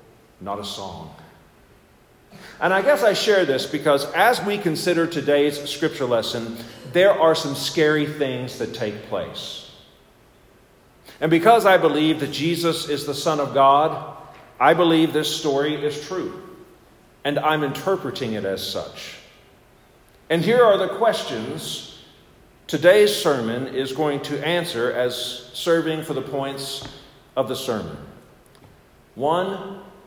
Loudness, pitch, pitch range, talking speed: -21 LUFS, 150 Hz, 135-170 Hz, 135 wpm